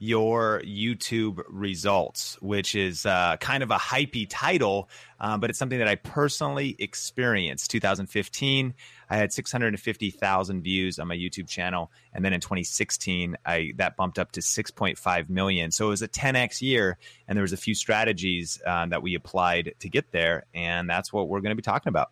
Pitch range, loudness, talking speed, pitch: 95-115 Hz, -26 LUFS, 185 wpm, 100 Hz